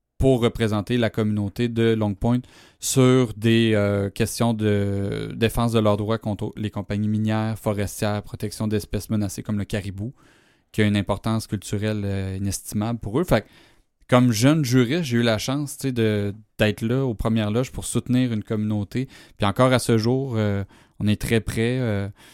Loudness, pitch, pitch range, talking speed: -23 LUFS, 110 Hz, 105-120 Hz, 175 wpm